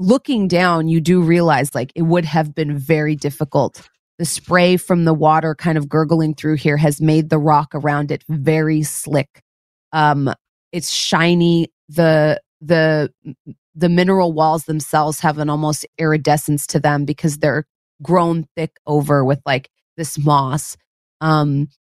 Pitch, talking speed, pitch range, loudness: 155 Hz, 150 wpm, 150-165 Hz, -17 LUFS